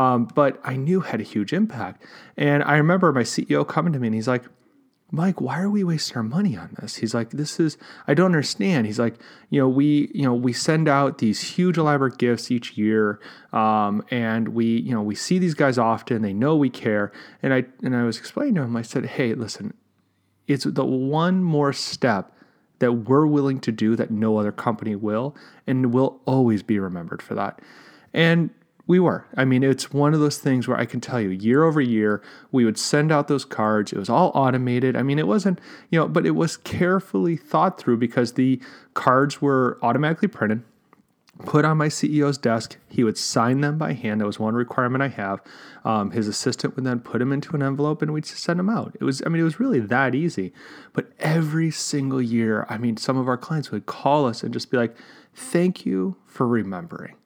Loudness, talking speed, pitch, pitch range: -22 LUFS, 220 wpm, 130 Hz, 115-155 Hz